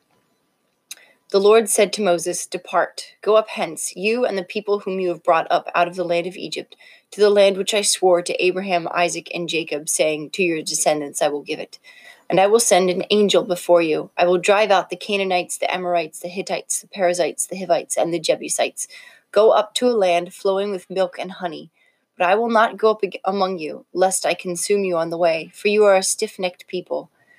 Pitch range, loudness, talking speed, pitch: 175-205 Hz, -19 LUFS, 220 wpm, 185 Hz